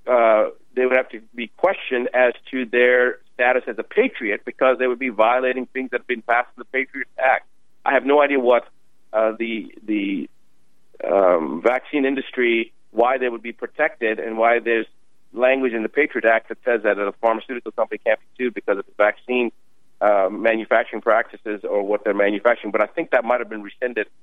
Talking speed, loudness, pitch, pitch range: 200 wpm, -20 LUFS, 125 Hz, 115-130 Hz